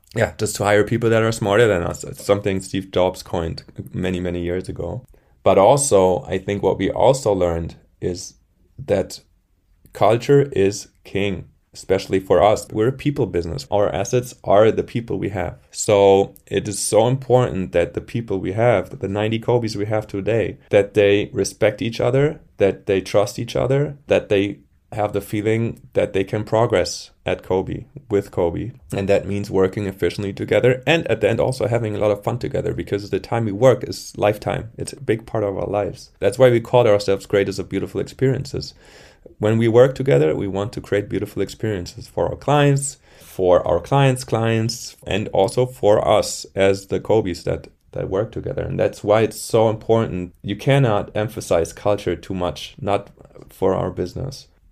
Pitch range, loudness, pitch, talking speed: 95-120 Hz, -20 LUFS, 105 Hz, 185 wpm